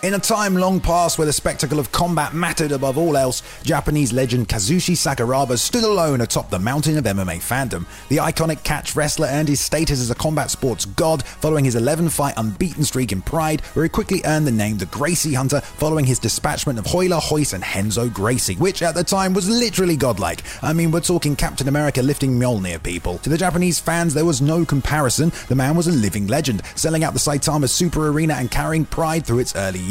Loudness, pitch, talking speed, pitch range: -19 LUFS, 150 Hz, 215 wpm, 125-165 Hz